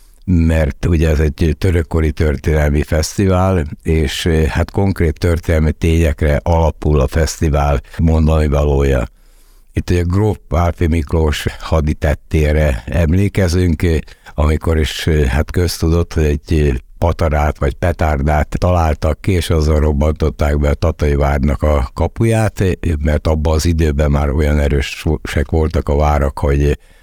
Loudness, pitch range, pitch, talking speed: -15 LUFS, 75-85 Hz, 80 Hz, 120 wpm